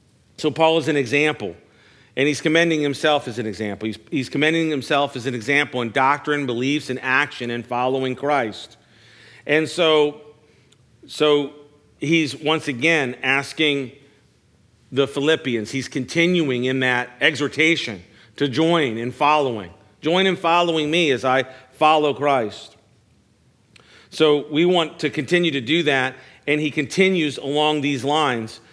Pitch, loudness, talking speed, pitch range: 145 Hz, -20 LUFS, 140 wpm, 125-155 Hz